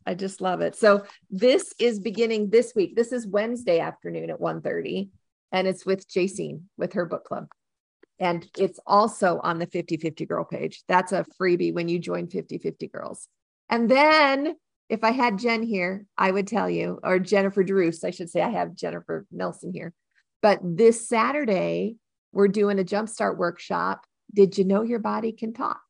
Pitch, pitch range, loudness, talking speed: 200 Hz, 180-225 Hz, -24 LUFS, 185 wpm